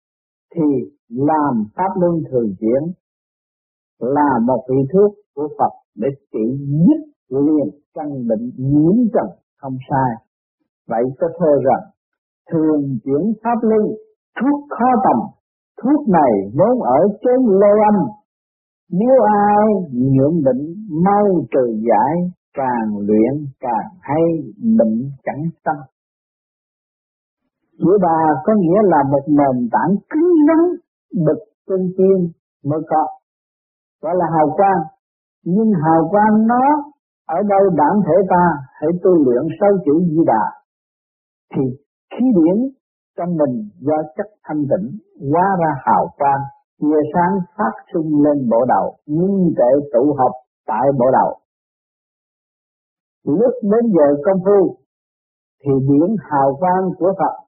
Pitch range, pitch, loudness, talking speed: 140-205 Hz, 165 Hz, -16 LUFS, 135 wpm